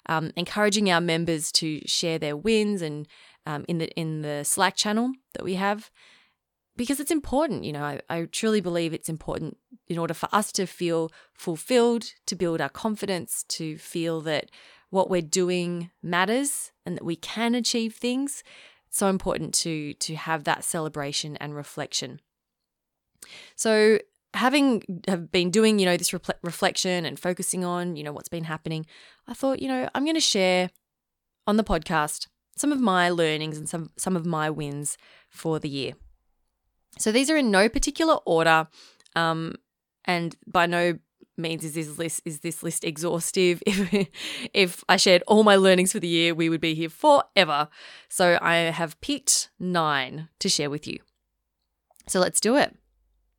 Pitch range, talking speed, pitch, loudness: 160-205 Hz, 170 wpm, 175 Hz, -25 LUFS